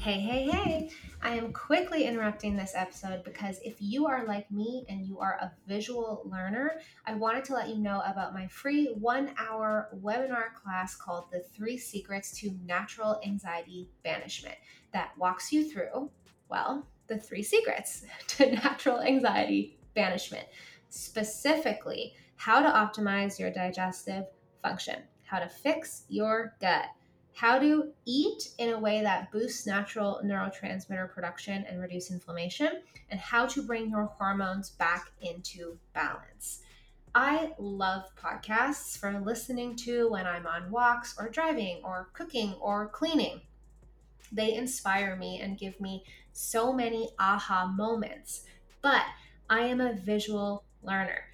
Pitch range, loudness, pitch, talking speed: 190-240 Hz, -31 LUFS, 210 Hz, 140 wpm